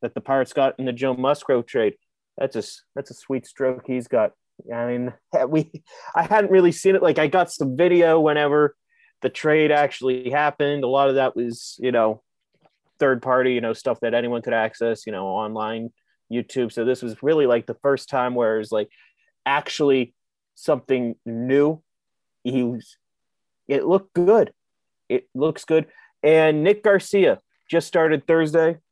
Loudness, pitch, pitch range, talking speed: -21 LUFS, 135 Hz, 120-160 Hz, 175 wpm